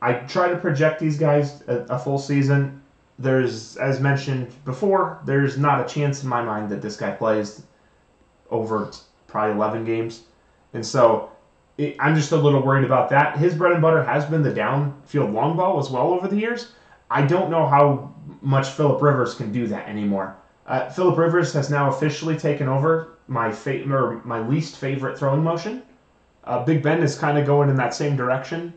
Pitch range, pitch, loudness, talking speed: 125-155 Hz, 140 Hz, -21 LUFS, 190 wpm